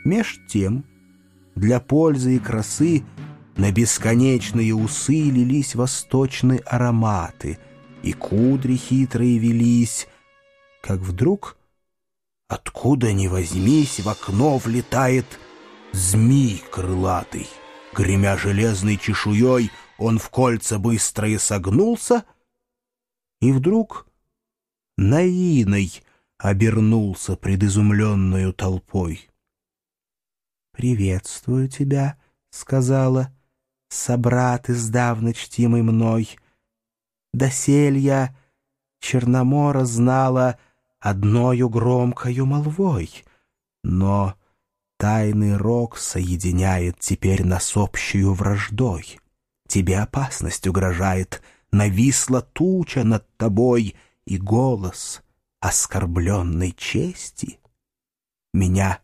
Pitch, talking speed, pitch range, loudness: 115 Hz, 75 wpm, 100-130 Hz, -20 LUFS